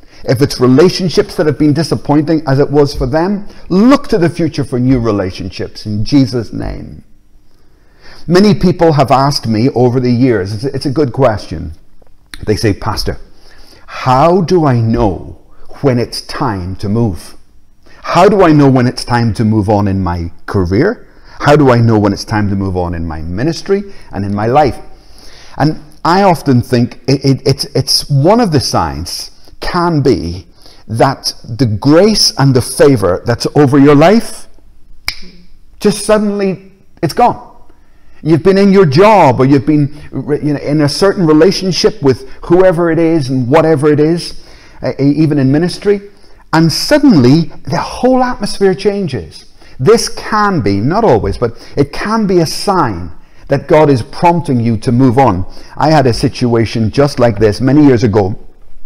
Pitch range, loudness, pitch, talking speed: 115-170 Hz, -11 LUFS, 140 Hz, 165 wpm